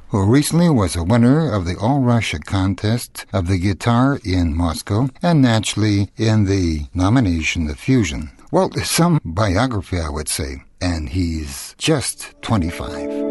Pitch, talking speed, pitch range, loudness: 100 Hz, 145 wpm, 85-120 Hz, -18 LUFS